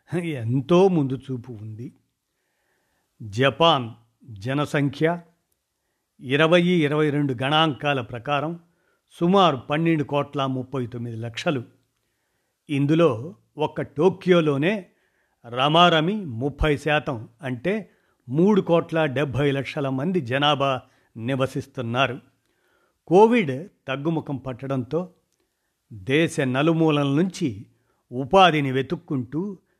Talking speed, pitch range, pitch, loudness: 80 wpm, 130-165 Hz, 145 Hz, -22 LUFS